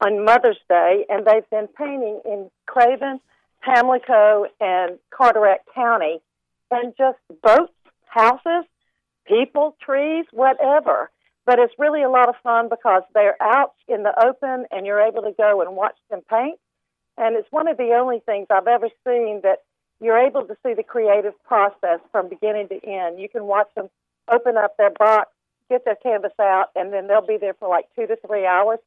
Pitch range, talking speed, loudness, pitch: 205-250 Hz, 180 wpm, -19 LUFS, 225 Hz